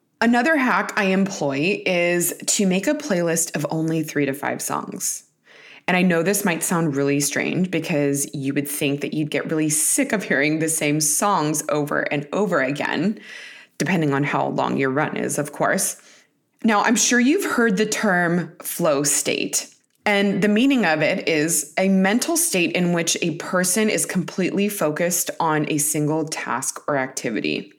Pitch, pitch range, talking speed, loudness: 175 Hz, 155-205 Hz, 175 wpm, -20 LUFS